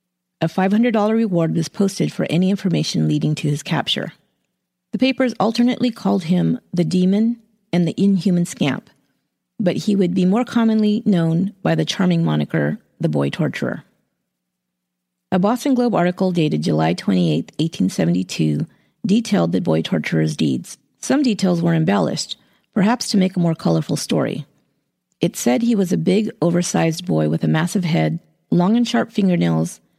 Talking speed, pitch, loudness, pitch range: 155 wpm, 180 Hz, -19 LUFS, 150-210 Hz